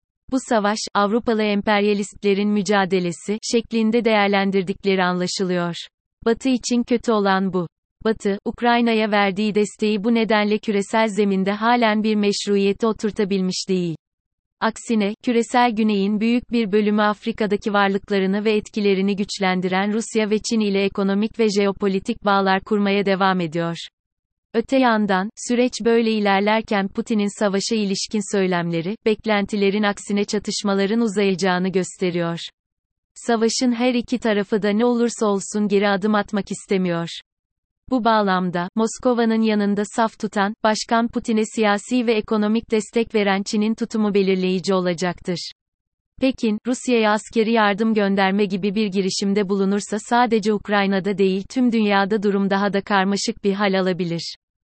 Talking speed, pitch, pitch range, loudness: 125 wpm, 205 Hz, 195-225 Hz, -20 LUFS